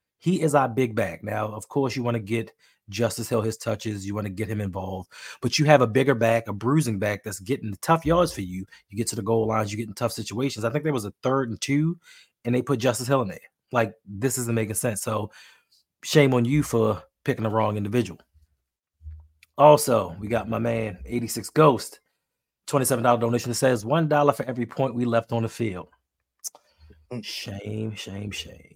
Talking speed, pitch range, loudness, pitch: 210 wpm, 105-130 Hz, -24 LUFS, 115 Hz